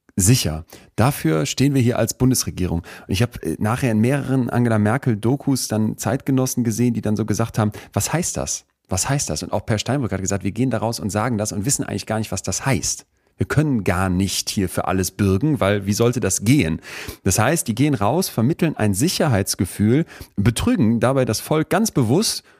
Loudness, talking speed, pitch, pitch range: -20 LUFS, 200 wpm, 110 Hz, 100-130 Hz